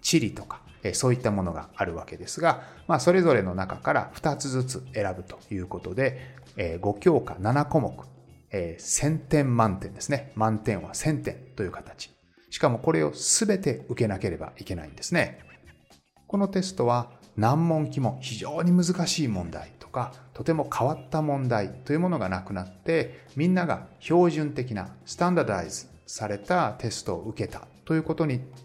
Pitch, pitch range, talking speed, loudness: 125 Hz, 95-150 Hz, 320 characters per minute, -27 LUFS